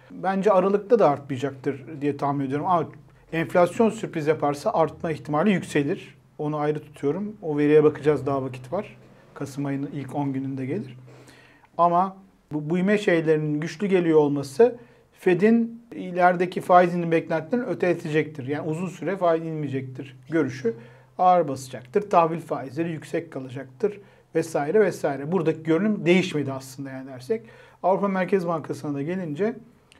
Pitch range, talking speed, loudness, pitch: 140-180 Hz, 135 wpm, -24 LUFS, 160 Hz